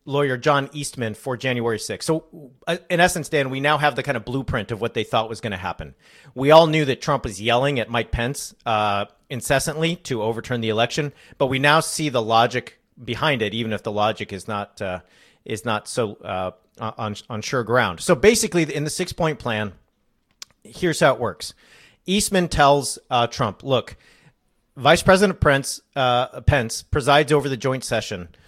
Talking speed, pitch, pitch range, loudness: 185 wpm, 130 Hz, 110-150 Hz, -21 LUFS